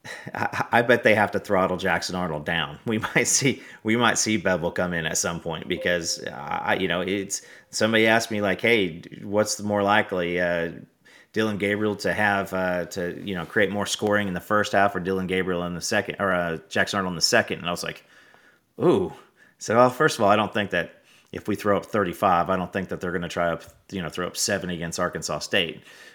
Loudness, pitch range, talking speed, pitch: -24 LUFS, 90-105 Hz, 230 wpm, 95 Hz